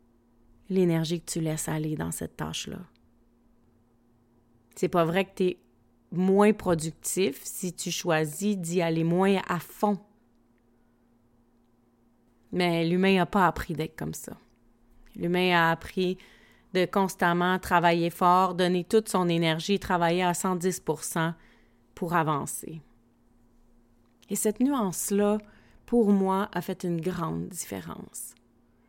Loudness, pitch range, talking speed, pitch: -27 LUFS, 120-185 Hz, 120 wpm, 165 Hz